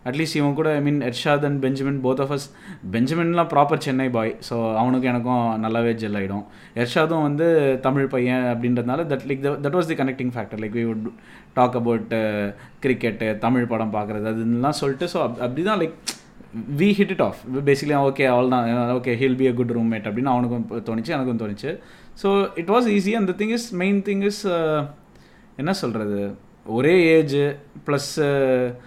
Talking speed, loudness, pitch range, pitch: 175 wpm, -22 LUFS, 120-150 Hz, 130 Hz